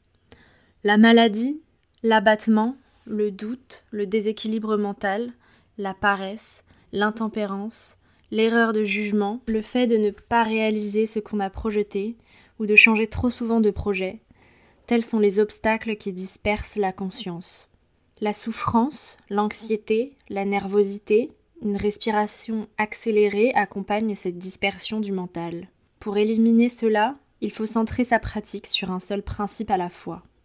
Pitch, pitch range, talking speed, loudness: 215 Hz, 205-225 Hz, 130 wpm, -23 LUFS